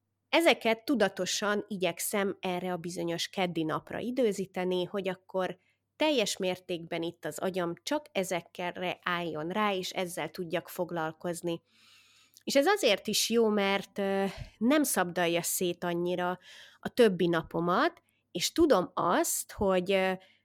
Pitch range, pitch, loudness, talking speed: 175-210 Hz, 185 Hz, -30 LUFS, 120 wpm